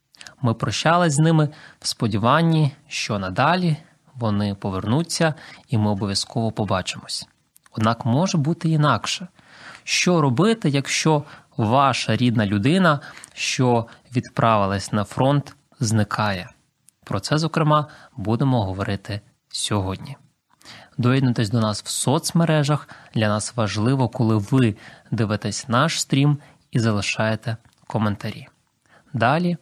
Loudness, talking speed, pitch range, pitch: -21 LUFS, 105 wpm, 110-150 Hz, 125 Hz